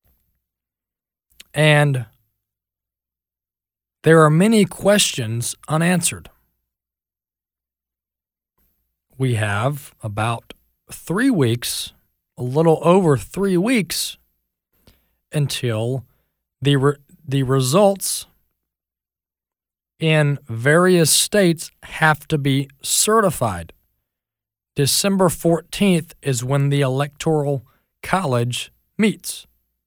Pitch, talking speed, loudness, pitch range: 135 Hz, 70 wpm, -18 LUFS, 100-160 Hz